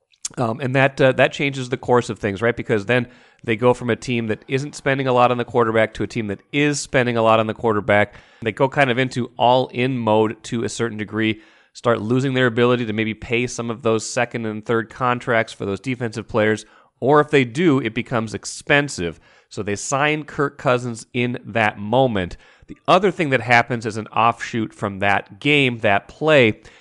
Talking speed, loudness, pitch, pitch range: 210 wpm, -20 LUFS, 120 Hz, 110-130 Hz